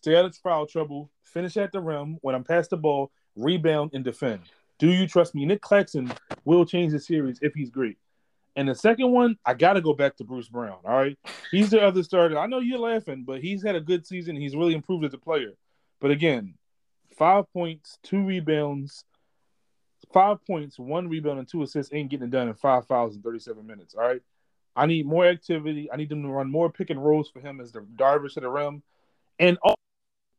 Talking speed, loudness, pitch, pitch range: 220 wpm, -25 LUFS, 155 Hz, 140-180 Hz